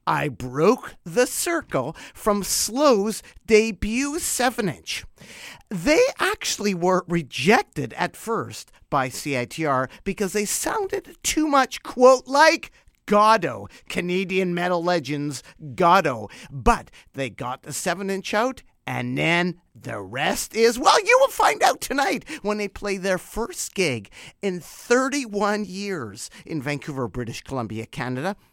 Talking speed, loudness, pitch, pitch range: 130 wpm, -22 LUFS, 195 Hz, 150-225 Hz